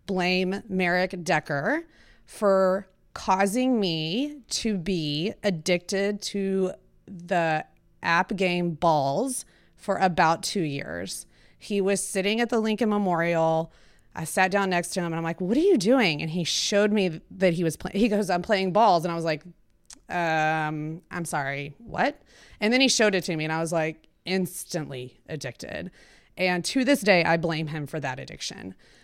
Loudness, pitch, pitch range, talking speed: -25 LUFS, 185 Hz, 160-200 Hz, 170 wpm